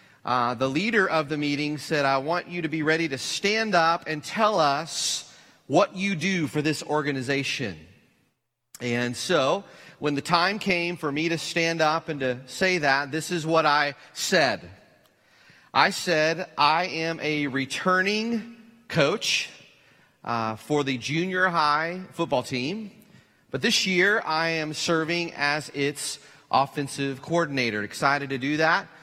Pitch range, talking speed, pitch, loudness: 140-175 Hz, 150 wpm, 155 Hz, -25 LUFS